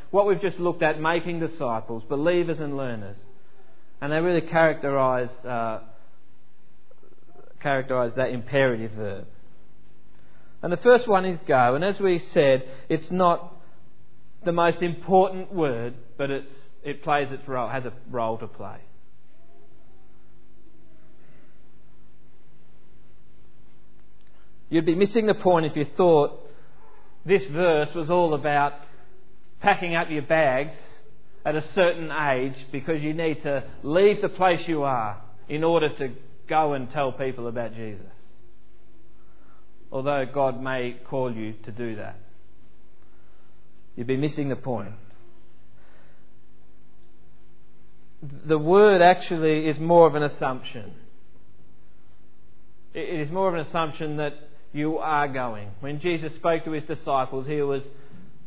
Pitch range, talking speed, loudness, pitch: 125-165 Hz, 125 wpm, -24 LUFS, 145 Hz